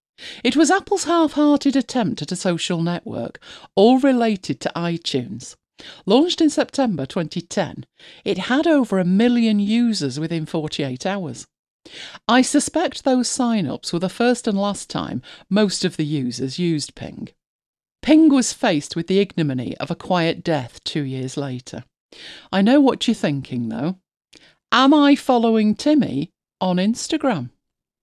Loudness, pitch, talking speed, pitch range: -20 LUFS, 205 Hz, 145 wpm, 165-260 Hz